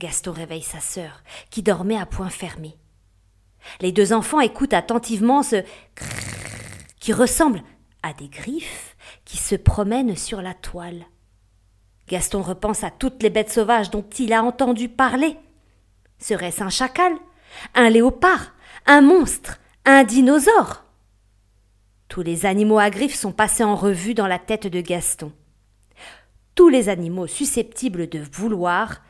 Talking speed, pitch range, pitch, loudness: 140 wpm, 160-240 Hz, 205 Hz, -19 LUFS